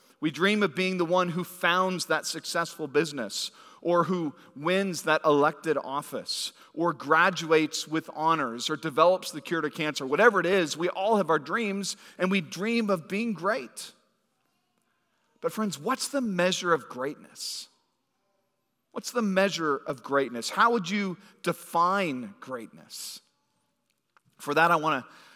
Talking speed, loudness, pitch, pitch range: 150 wpm, -27 LUFS, 175 Hz, 160-195 Hz